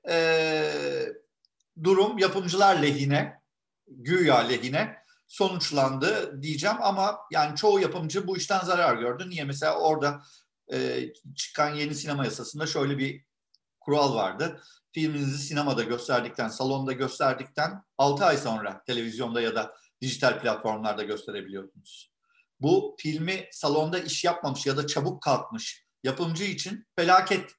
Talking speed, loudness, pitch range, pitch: 115 wpm, -27 LUFS, 135-190 Hz, 155 Hz